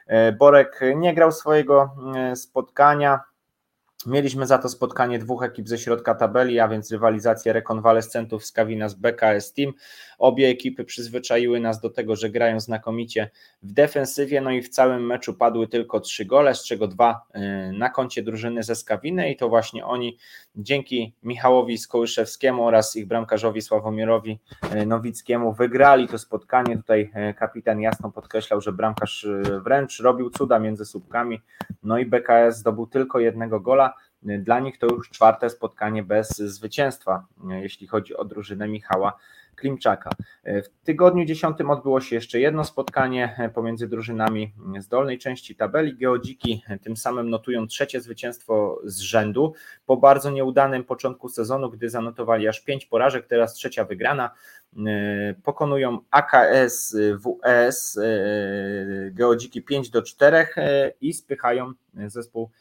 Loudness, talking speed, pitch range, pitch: -22 LUFS, 135 wpm, 110-130 Hz, 115 Hz